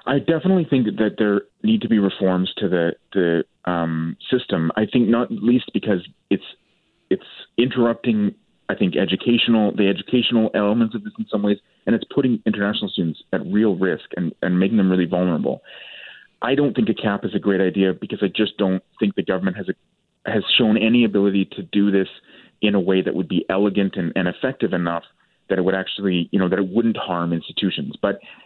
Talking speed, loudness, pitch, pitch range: 200 wpm, -20 LUFS, 100 Hz, 95-115 Hz